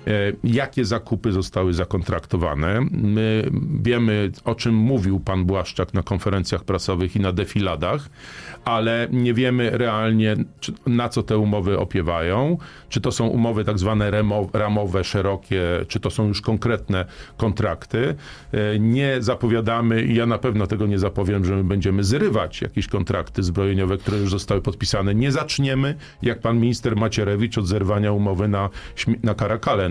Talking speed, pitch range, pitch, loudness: 140 wpm, 100-115 Hz, 105 Hz, -22 LUFS